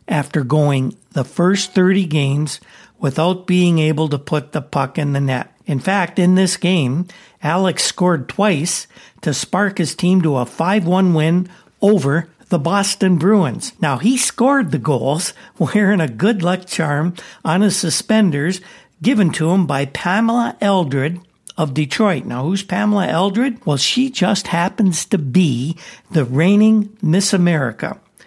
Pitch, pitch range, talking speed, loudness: 180 Hz, 155-200 Hz, 155 wpm, -17 LUFS